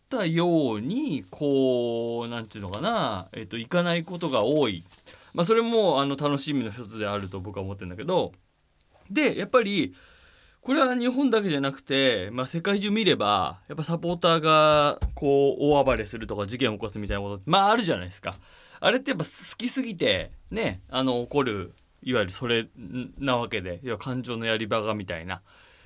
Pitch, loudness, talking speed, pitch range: 135 Hz, -25 LUFS, 350 characters per minute, 110-170 Hz